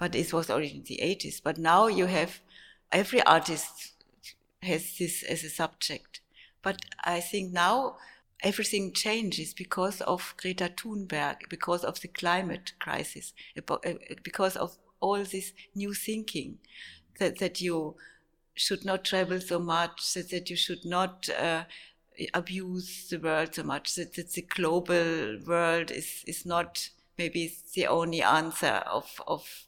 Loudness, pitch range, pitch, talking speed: -30 LUFS, 165-190 Hz, 175 Hz, 145 wpm